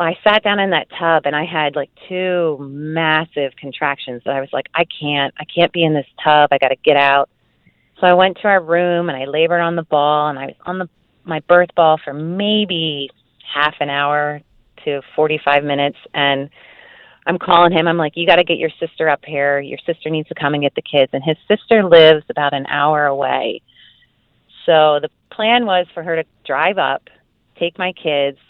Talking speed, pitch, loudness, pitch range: 210 wpm, 155 Hz, -16 LUFS, 145-170 Hz